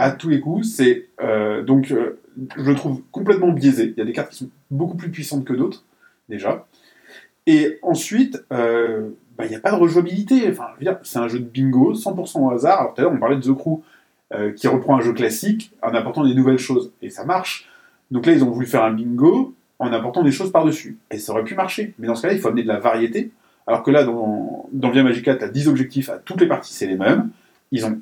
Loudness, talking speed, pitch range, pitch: -19 LUFS, 250 wpm, 120-175 Hz, 135 Hz